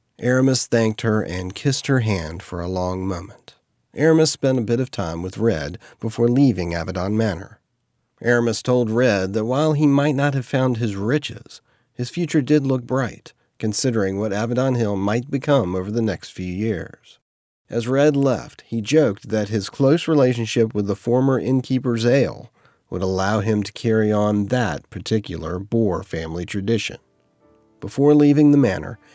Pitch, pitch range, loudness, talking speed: 115 Hz, 100-130 Hz, -20 LUFS, 165 wpm